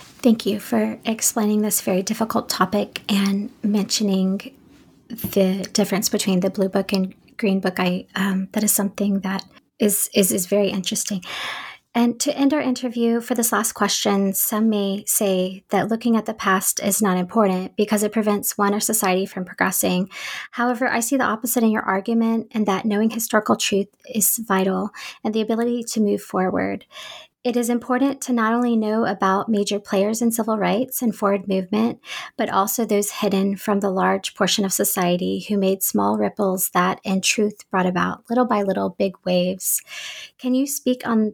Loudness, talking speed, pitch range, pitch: -21 LUFS, 180 wpm, 195-230 Hz, 205 Hz